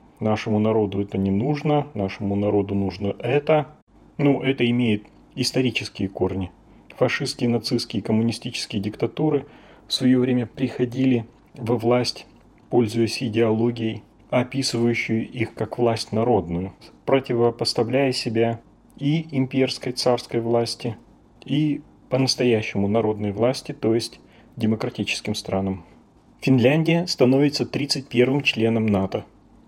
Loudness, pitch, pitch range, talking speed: -23 LUFS, 120 Hz, 110-130 Hz, 105 wpm